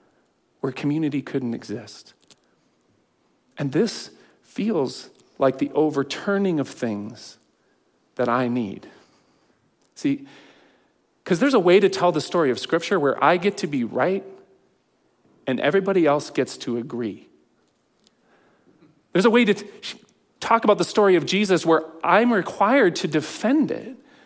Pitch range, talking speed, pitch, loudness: 135-210 Hz, 135 wpm, 175 Hz, -22 LUFS